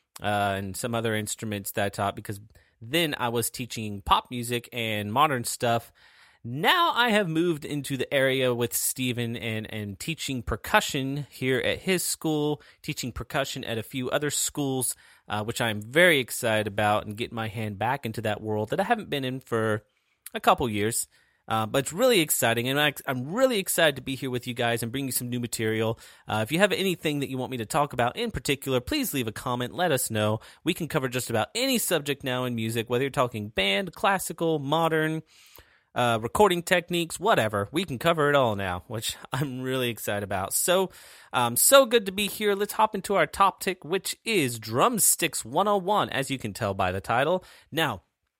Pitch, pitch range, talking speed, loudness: 130 Hz, 115-165 Hz, 200 wpm, -26 LUFS